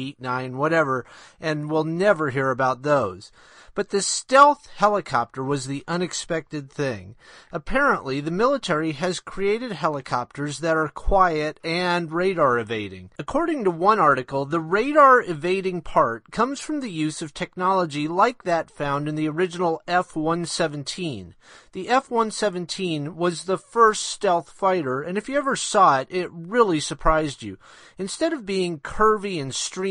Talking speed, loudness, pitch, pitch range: 150 wpm, -22 LUFS, 170 Hz, 145-195 Hz